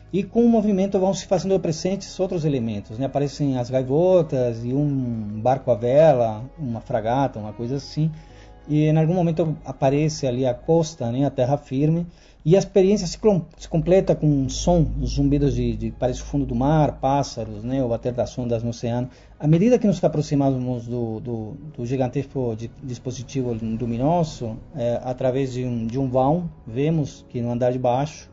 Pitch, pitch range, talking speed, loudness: 135 Hz, 120-160 Hz, 185 wpm, -22 LUFS